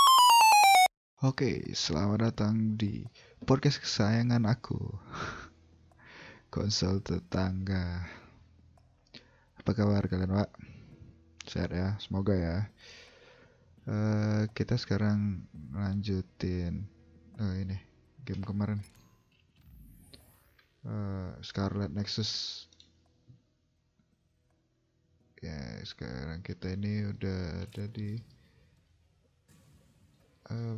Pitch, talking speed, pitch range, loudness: 100 Hz, 70 wpm, 95-115 Hz, -30 LUFS